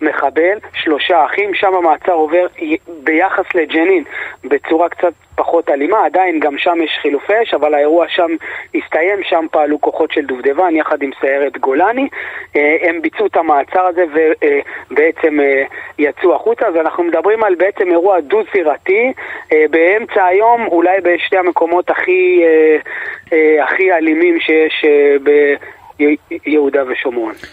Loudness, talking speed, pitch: -13 LUFS, 125 wpm, 175 Hz